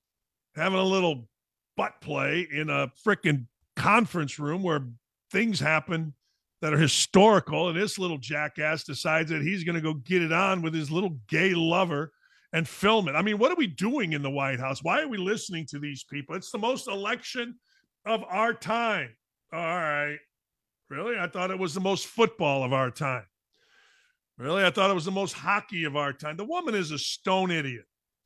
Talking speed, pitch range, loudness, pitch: 195 wpm, 150-205 Hz, -27 LUFS, 170 Hz